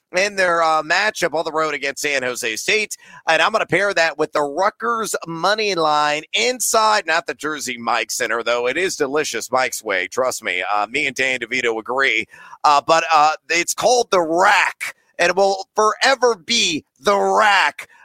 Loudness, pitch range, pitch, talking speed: -18 LUFS, 145-200 Hz, 165 Hz, 185 wpm